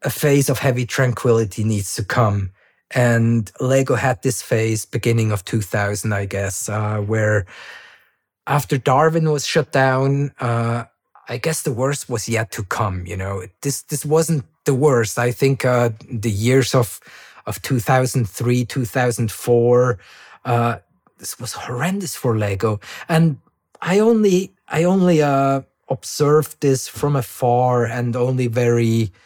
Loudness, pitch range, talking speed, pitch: -19 LUFS, 110-140 Hz, 140 wpm, 125 Hz